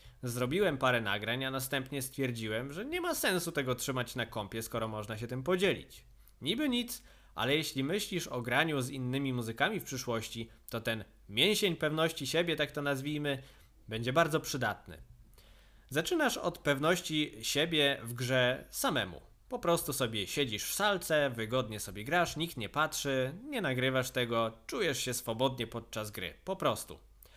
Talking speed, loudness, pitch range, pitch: 155 wpm, -33 LUFS, 115-155 Hz, 130 Hz